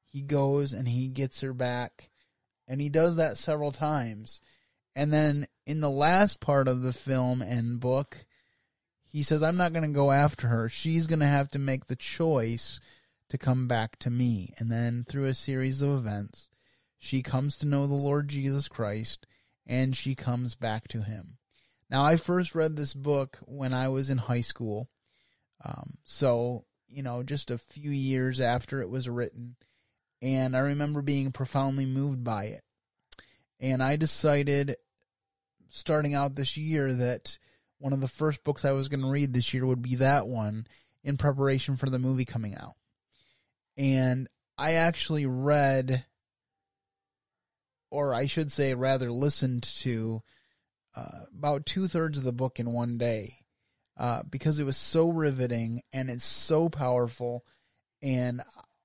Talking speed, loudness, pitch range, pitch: 165 wpm, -29 LUFS, 120-140 Hz, 130 Hz